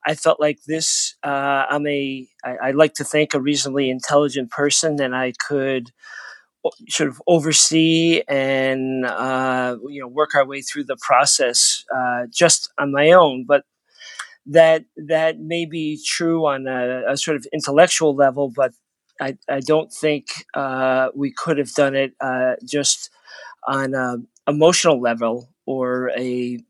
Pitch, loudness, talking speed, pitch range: 140 Hz, -19 LUFS, 155 wpm, 130-155 Hz